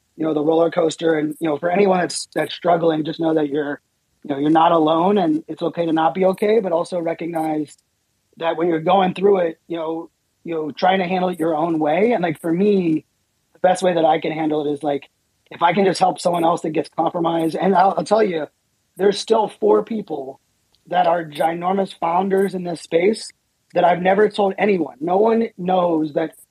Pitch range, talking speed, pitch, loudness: 155-185 Hz, 220 wpm, 165 Hz, -19 LUFS